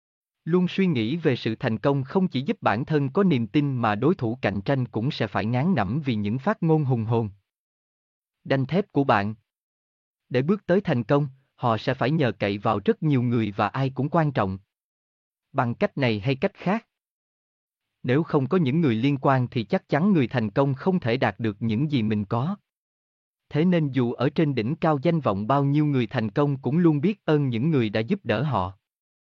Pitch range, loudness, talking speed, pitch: 115-155 Hz, -24 LUFS, 215 wpm, 135 Hz